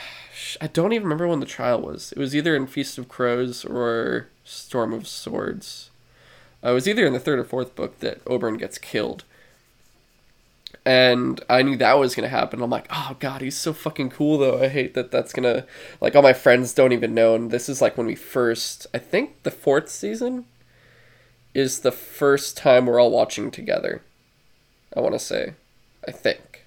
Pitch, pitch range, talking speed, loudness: 130 Hz, 120-140 Hz, 200 wpm, -22 LUFS